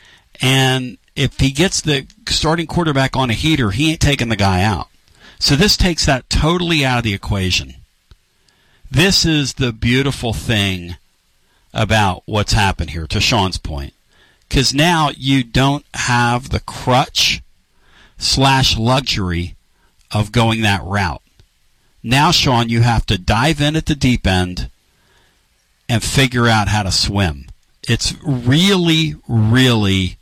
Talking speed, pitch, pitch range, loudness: 140 wpm, 120 Hz, 100-140 Hz, -15 LUFS